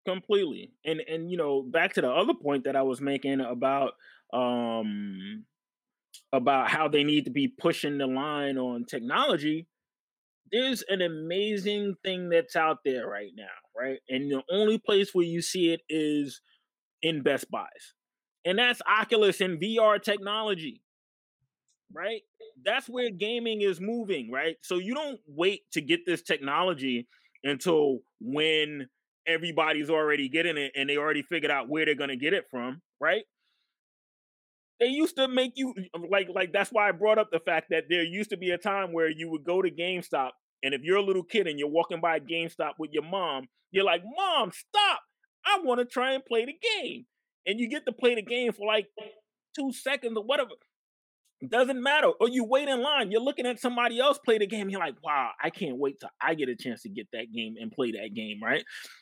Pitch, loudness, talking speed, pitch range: 180 Hz, -28 LUFS, 195 wpm, 150-230 Hz